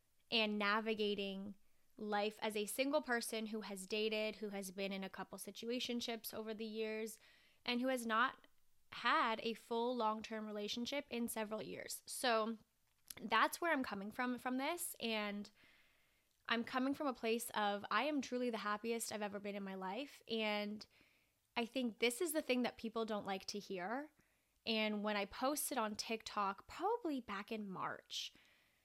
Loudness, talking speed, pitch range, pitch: -41 LUFS, 170 wpm, 210-245 Hz, 220 Hz